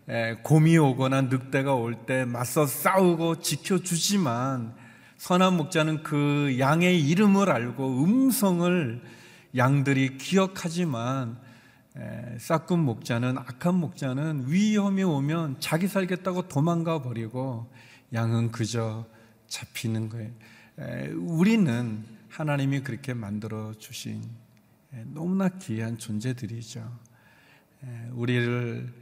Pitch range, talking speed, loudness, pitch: 115-165 Hz, 235 characters per minute, -26 LUFS, 130 Hz